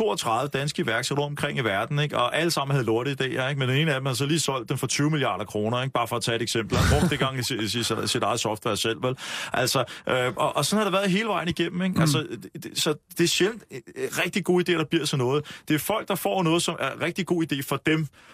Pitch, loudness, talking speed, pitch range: 145 Hz, -25 LUFS, 270 wpm, 125-170 Hz